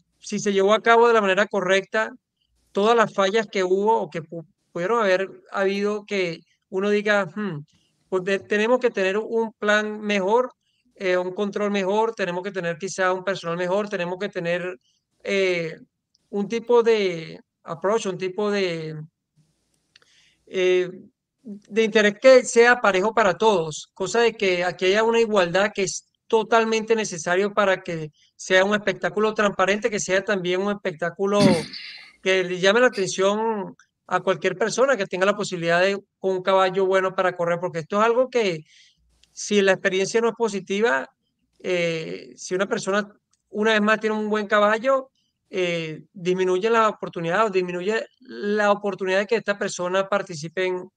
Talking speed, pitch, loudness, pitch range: 160 wpm, 195 Hz, -22 LUFS, 185-215 Hz